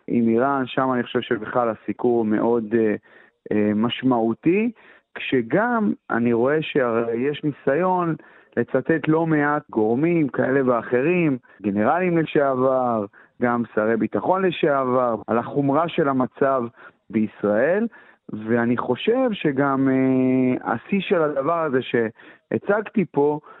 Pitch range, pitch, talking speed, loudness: 115-155 Hz, 130 Hz, 110 wpm, -21 LUFS